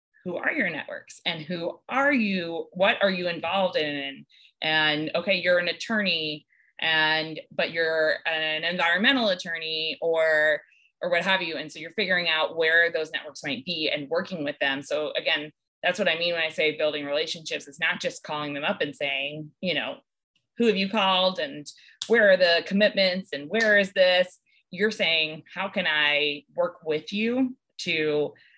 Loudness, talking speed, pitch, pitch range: -25 LUFS, 180 wpm, 170 Hz, 155-190 Hz